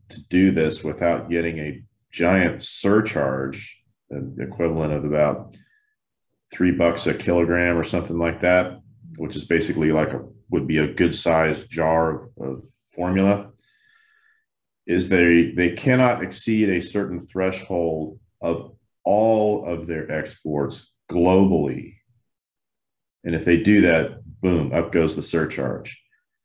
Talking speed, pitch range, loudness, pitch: 130 wpm, 80-100 Hz, -21 LUFS, 85 Hz